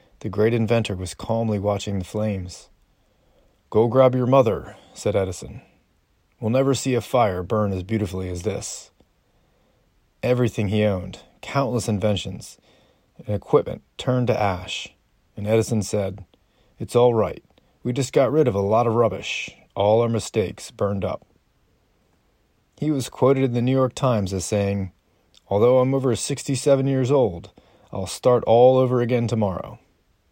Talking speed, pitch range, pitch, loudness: 150 wpm, 100-125 Hz, 110 Hz, -22 LUFS